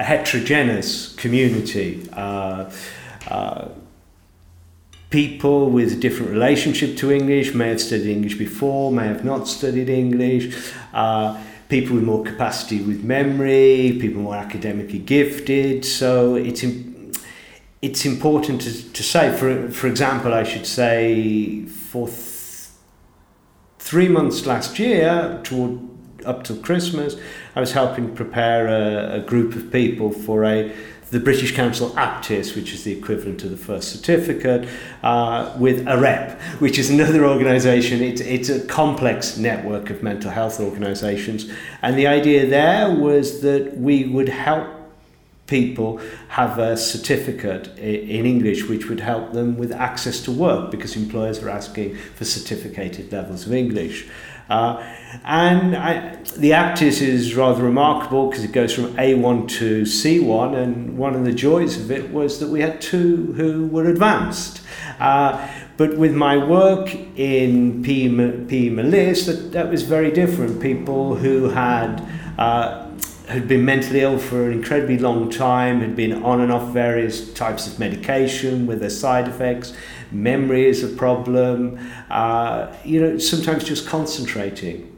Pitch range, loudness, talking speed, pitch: 110-140 Hz, -19 LUFS, 145 wpm, 125 Hz